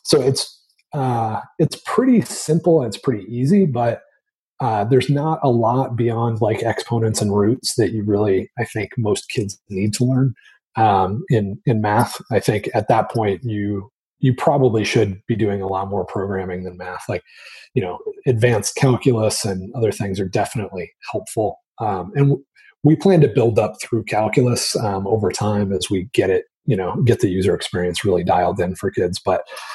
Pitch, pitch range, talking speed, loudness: 115 Hz, 100-135 Hz, 185 wpm, -19 LUFS